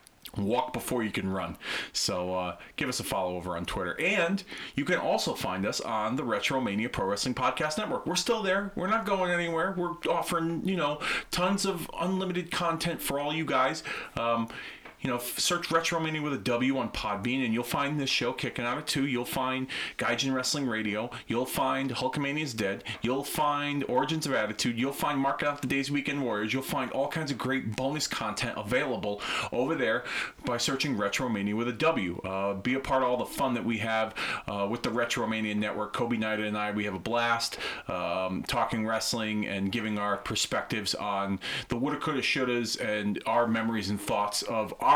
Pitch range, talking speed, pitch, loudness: 110-150 Hz, 205 wpm, 130 Hz, -30 LUFS